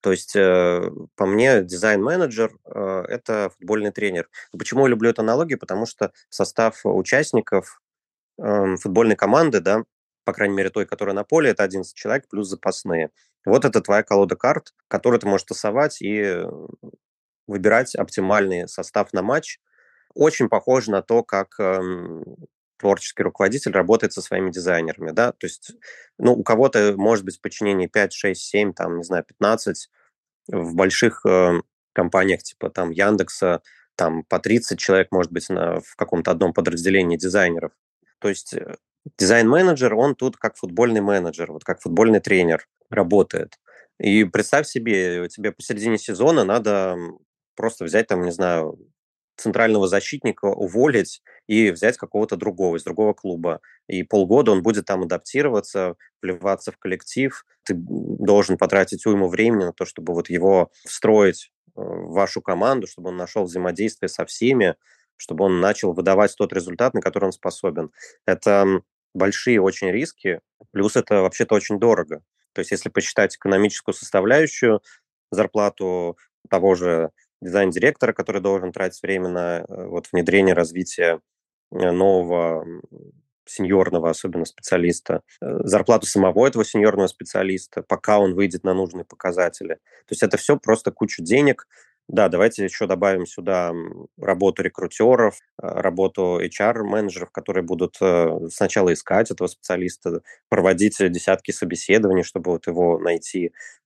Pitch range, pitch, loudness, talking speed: 90-105 Hz, 95 Hz, -20 LUFS, 140 wpm